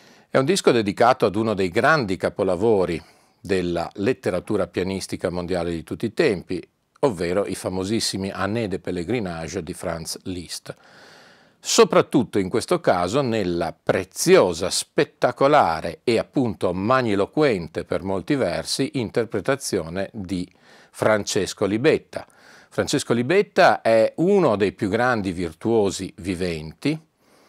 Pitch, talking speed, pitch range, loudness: 95 Hz, 115 wpm, 90-115 Hz, -22 LUFS